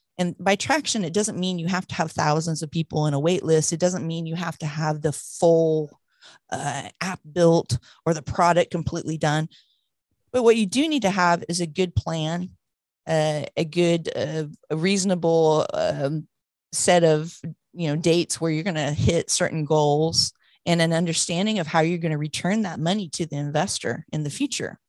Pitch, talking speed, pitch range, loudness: 165 Hz, 195 wpm, 155-180 Hz, -23 LUFS